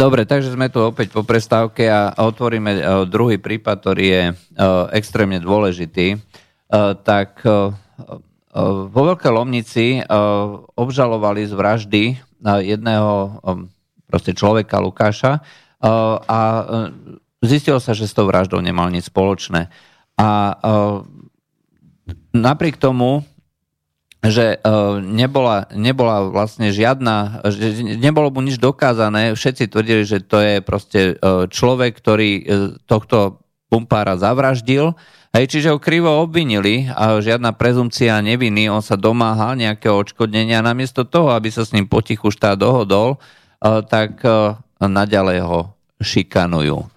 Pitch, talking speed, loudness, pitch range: 110 Hz, 110 wpm, -16 LUFS, 100-120 Hz